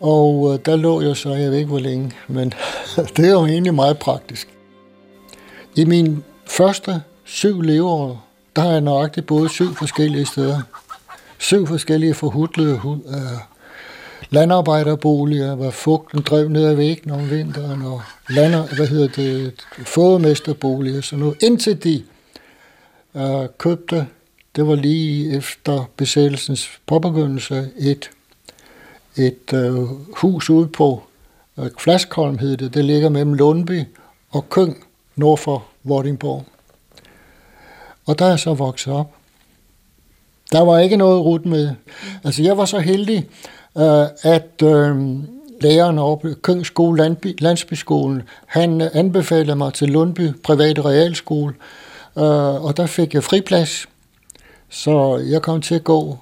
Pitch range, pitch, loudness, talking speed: 140-165 Hz, 150 Hz, -17 LUFS, 135 wpm